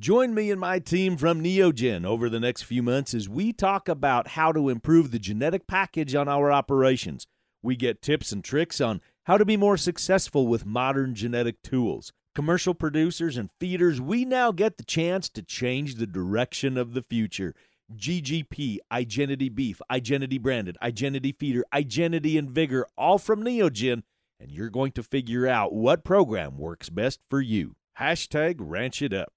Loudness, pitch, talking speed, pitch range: -26 LUFS, 140 Hz, 170 wpm, 120-170 Hz